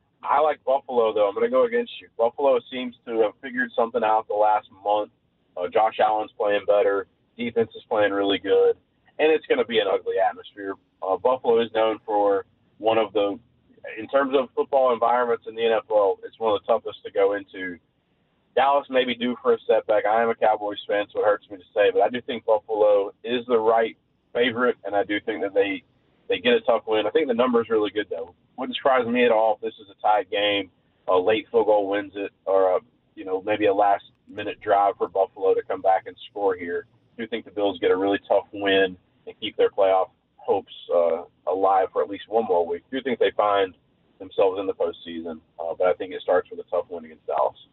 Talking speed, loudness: 235 wpm, -23 LUFS